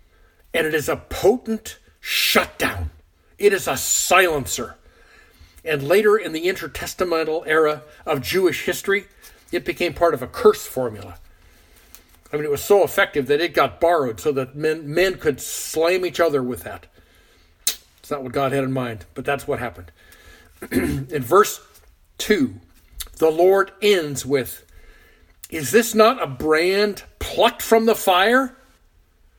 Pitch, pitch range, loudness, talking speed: 150 Hz, 115-195 Hz, -20 LUFS, 150 wpm